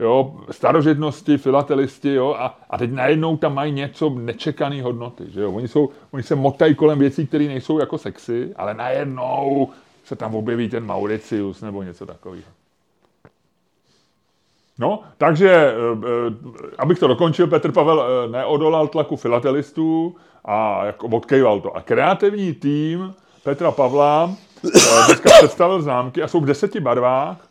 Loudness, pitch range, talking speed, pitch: -18 LUFS, 120-160 Hz, 145 wpm, 140 Hz